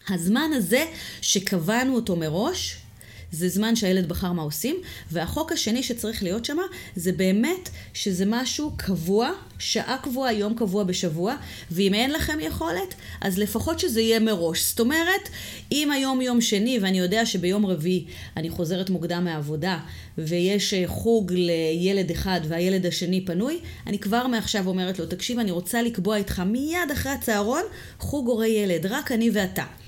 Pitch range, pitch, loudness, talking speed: 180-235 Hz, 200 Hz, -24 LUFS, 150 wpm